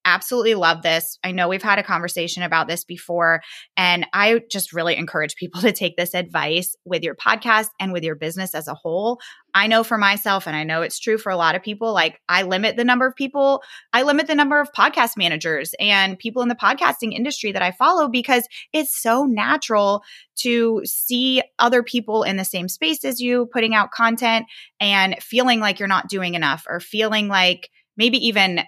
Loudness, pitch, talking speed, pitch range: -19 LUFS, 205 Hz, 205 wpm, 180-240 Hz